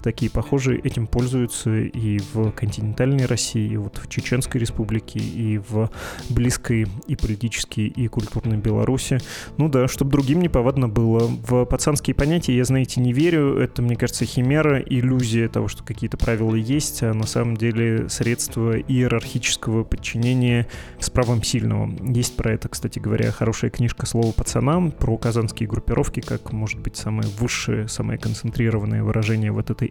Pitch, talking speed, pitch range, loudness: 115 Hz, 155 wpm, 110-125 Hz, -22 LUFS